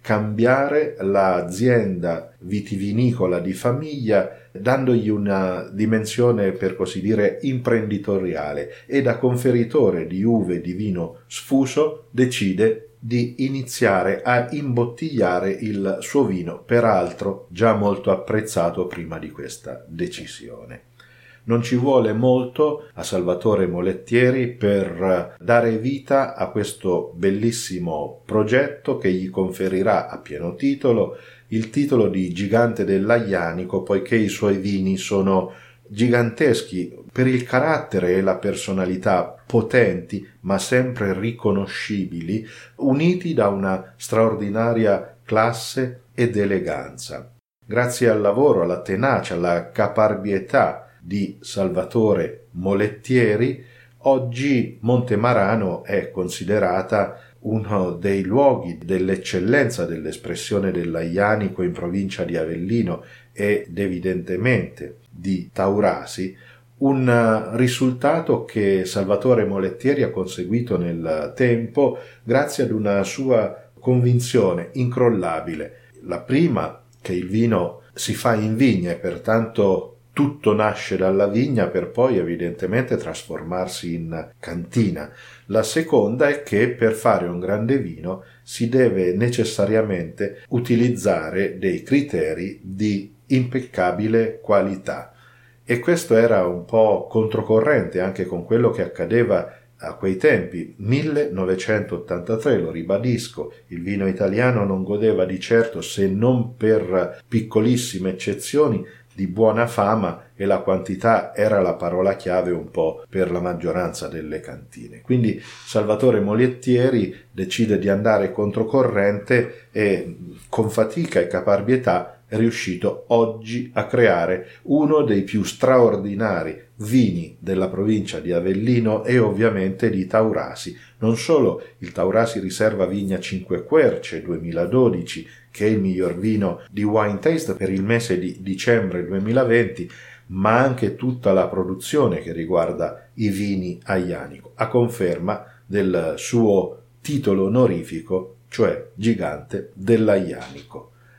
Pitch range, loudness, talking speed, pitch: 95-120 Hz, -21 LUFS, 115 wpm, 110 Hz